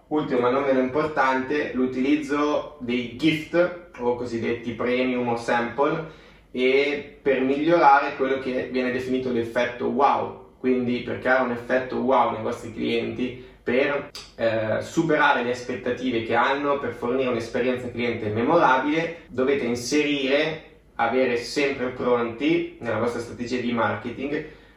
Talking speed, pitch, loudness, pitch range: 130 wpm, 130 Hz, -24 LUFS, 120-145 Hz